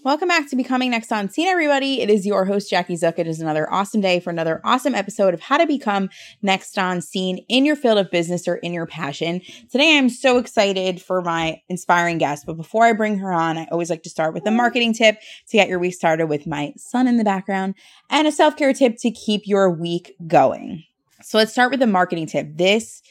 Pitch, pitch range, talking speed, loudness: 195 Hz, 170-240 Hz, 235 wpm, -19 LUFS